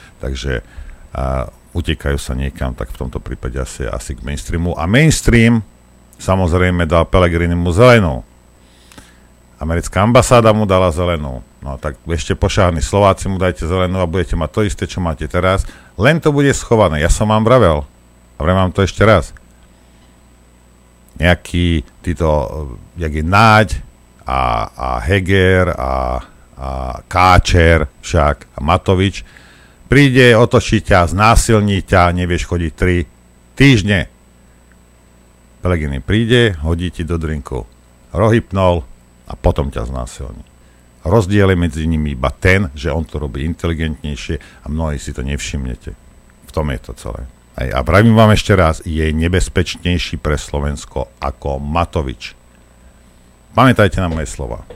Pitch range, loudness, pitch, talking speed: 65-95 Hz, -15 LUFS, 80 Hz, 135 wpm